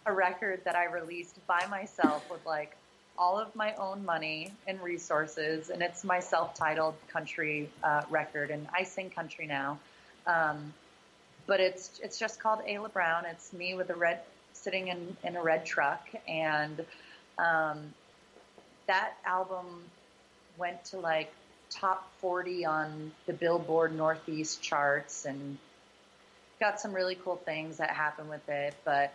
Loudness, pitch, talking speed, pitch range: -33 LUFS, 170 Hz, 150 wpm, 155-185 Hz